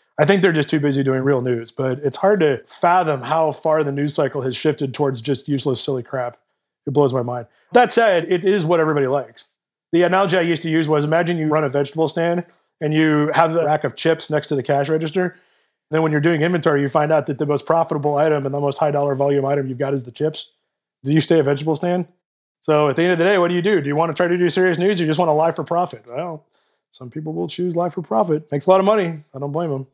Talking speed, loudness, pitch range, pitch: 275 wpm, -19 LUFS, 140-170 Hz, 155 Hz